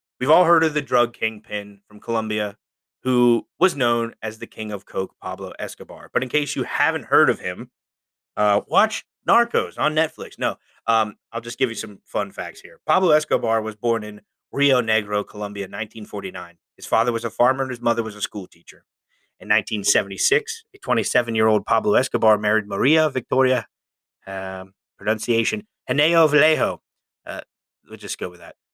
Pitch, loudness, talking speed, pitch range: 115 Hz, -21 LUFS, 180 wpm, 105-130 Hz